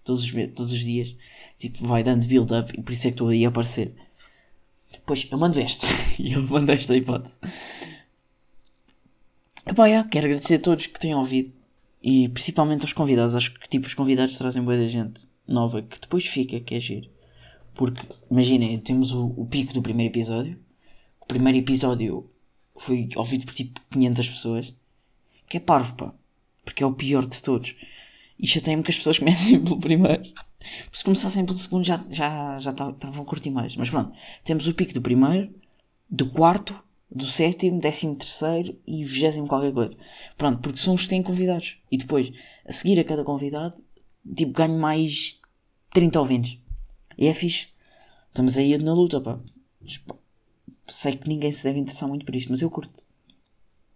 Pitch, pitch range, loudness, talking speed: 130 Hz, 120-155 Hz, -23 LUFS, 180 wpm